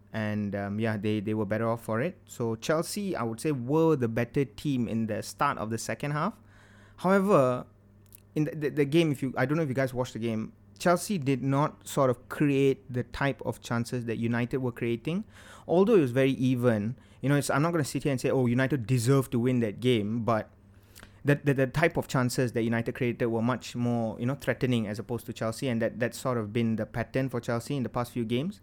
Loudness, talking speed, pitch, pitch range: -29 LUFS, 240 wpm, 120 Hz, 110-135 Hz